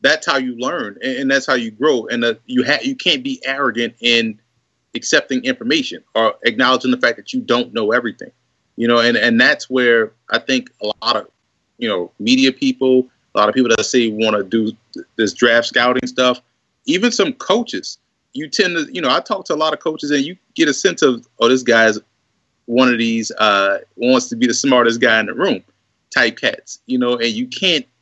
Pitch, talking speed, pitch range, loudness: 125 Hz, 220 wpm, 120-150 Hz, -16 LUFS